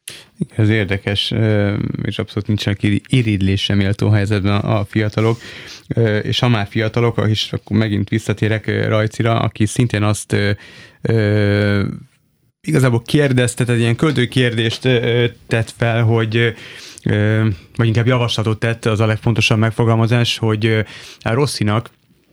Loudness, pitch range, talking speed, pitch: -17 LUFS, 105-120 Hz, 125 wpm, 110 Hz